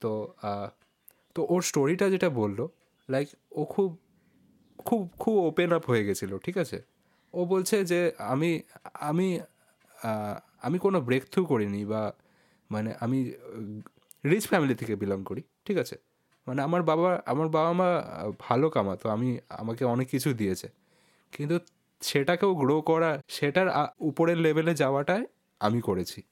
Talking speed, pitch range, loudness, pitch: 135 wpm, 115-175 Hz, -28 LUFS, 150 Hz